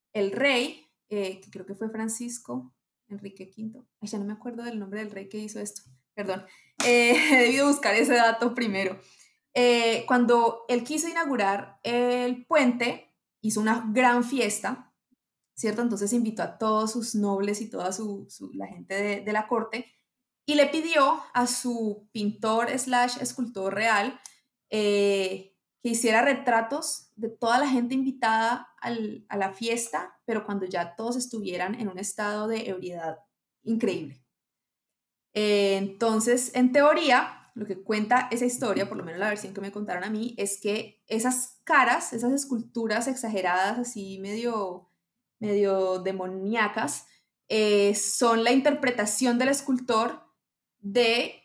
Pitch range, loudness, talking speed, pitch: 205-245 Hz, -26 LUFS, 150 wpm, 225 Hz